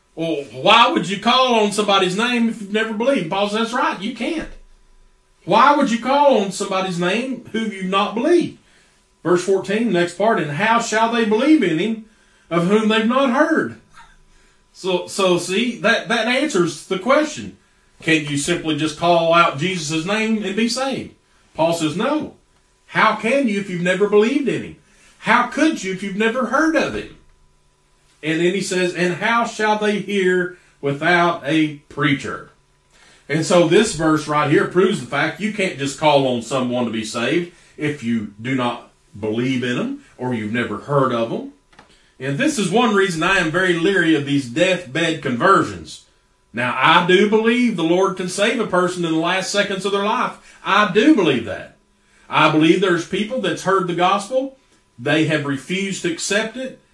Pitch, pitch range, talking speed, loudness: 190 Hz, 160-225 Hz, 185 wpm, -18 LUFS